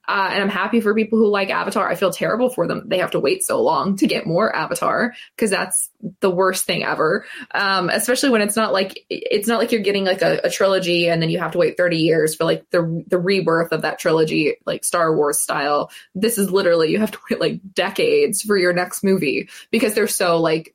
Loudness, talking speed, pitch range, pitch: -19 LUFS, 235 wpm, 170-220 Hz, 195 Hz